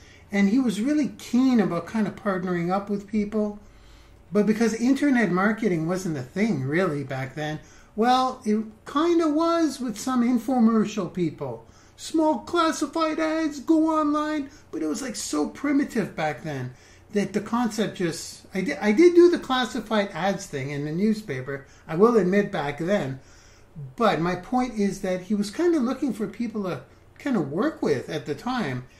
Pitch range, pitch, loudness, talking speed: 165-255 Hz, 210 Hz, -24 LUFS, 175 wpm